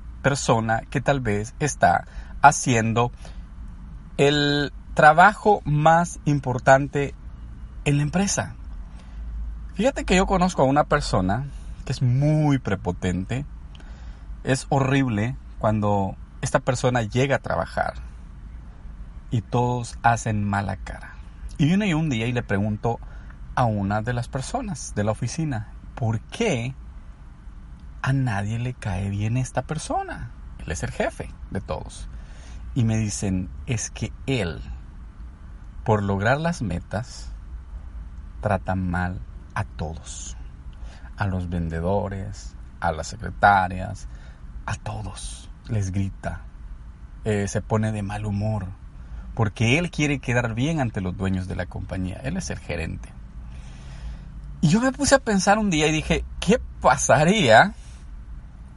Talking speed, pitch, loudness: 125 wpm, 100 Hz, -23 LUFS